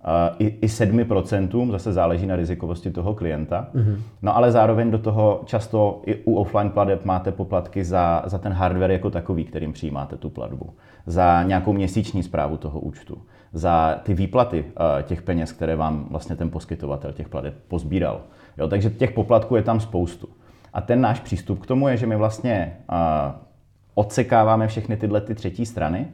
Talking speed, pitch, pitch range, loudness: 165 wpm, 95 Hz, 85-110 Hz, -22 LUFS